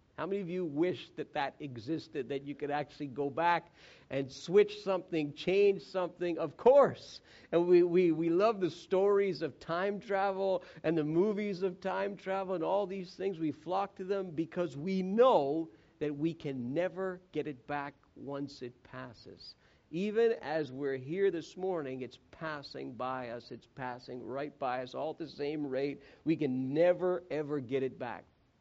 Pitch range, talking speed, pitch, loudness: 140-185 Hz, 180 wpm, 165 Hz, -33 LUFS